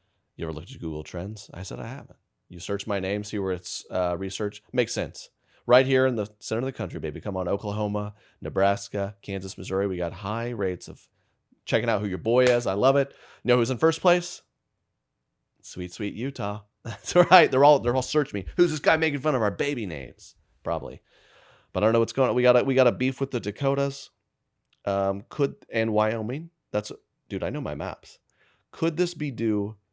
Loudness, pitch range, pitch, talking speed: -26 LUFS, 100-130 Hz, 110 Hz, 215 wpm